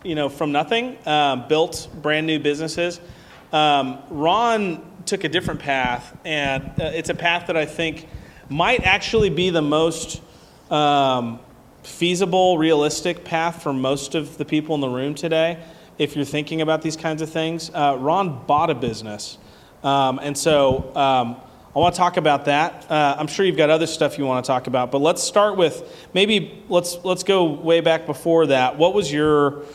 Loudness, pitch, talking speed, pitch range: -20 LUFS, 155 Hz, 185 wpm, 145-170 Hz